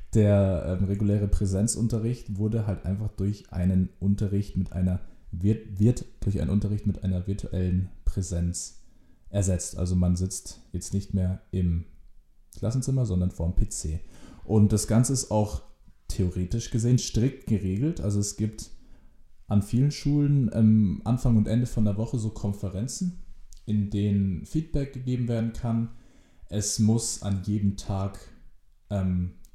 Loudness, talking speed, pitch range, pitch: -27 LUFS, 140 wpm, 90-110 Hz, 100 Hz